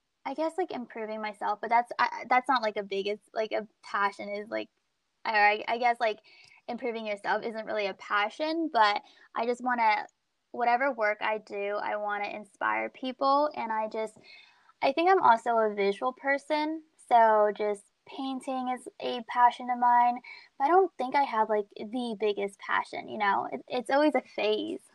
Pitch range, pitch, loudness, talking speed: 210-275 Hz, 235 Hz, -28 LUFS, 185 wpm